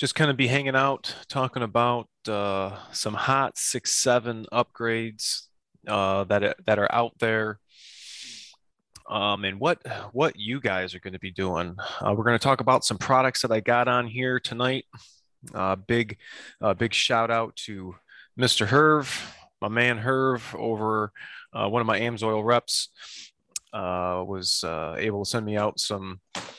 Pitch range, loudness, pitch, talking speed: 100-125 Hz, -25 LUFS, 115 Hz, 170 wpm